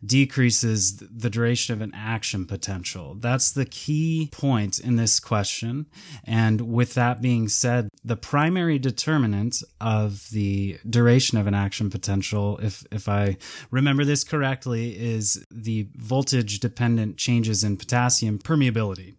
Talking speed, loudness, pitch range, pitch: 135 wpm, -23 LUFS, 105-130 Hz, 115 Hz